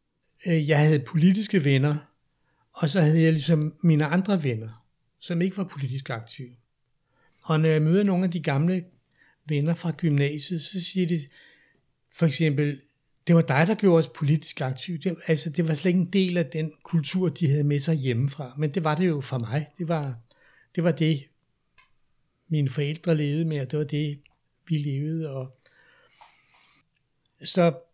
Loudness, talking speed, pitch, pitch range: -25 LUFS, 175 wpm, 155 Hz, 145-170 Hz